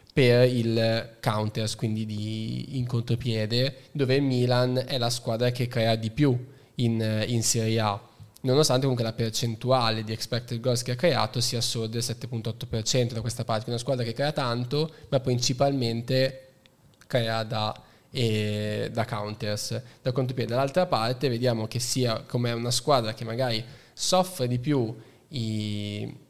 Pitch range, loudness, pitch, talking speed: 115-130 Hz, -27 LUFS, 120 Hz, 145 wpm